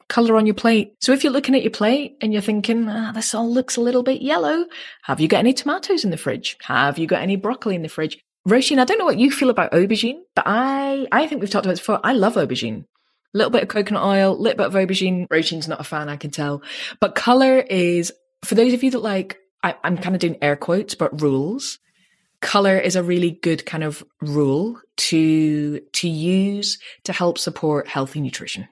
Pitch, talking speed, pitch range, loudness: 200 Hz, 235 wpm, 165-240 Hz, -20 LUFS